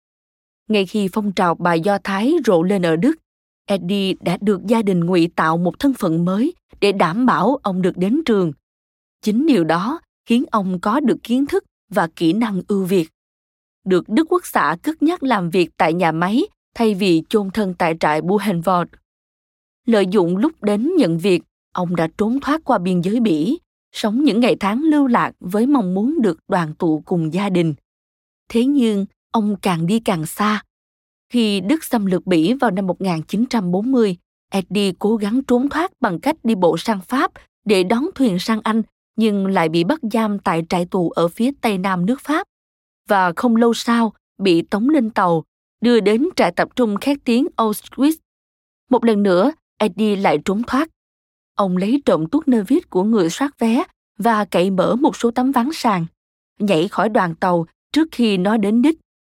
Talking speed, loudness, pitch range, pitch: 185 wpm, -18 LUFS, 180-245 Hz, 210 Hz